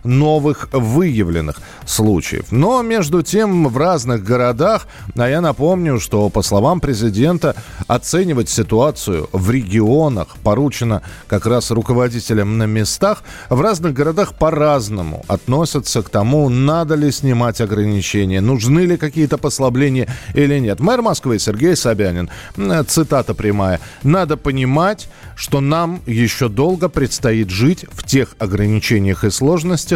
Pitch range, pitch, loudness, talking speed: 110-155 Hz, 125 Hz, -16 LUFS, 125 wpm